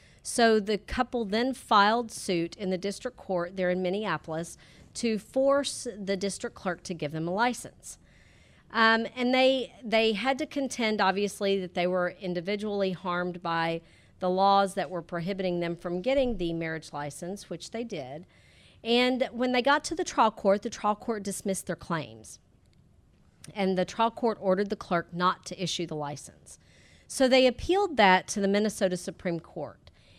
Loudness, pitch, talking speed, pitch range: -28 LUFS, 195 Hz, 170 wpm, 175-230 Hz